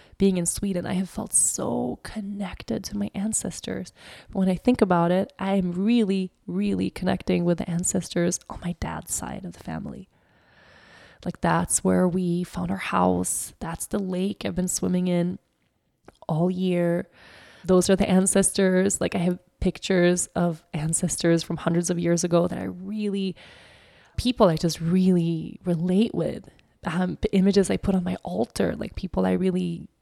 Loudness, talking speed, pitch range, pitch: -24 LUFS, 165 wpm, 175-195 Hz, 180 Hz